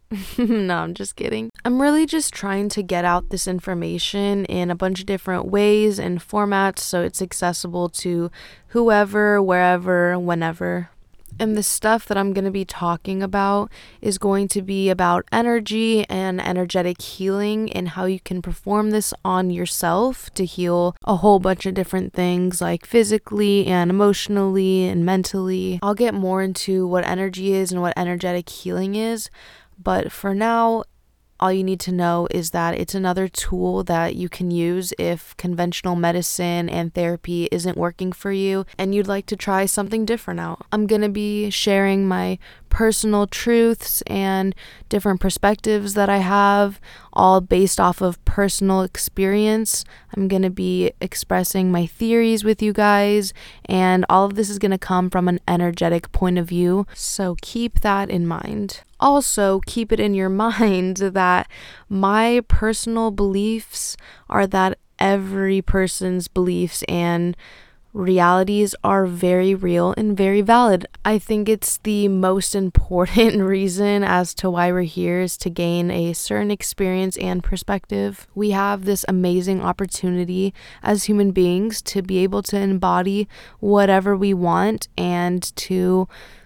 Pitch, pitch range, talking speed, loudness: 190 Hz, 180-205 Hz, 155 wpm, -20 LUFS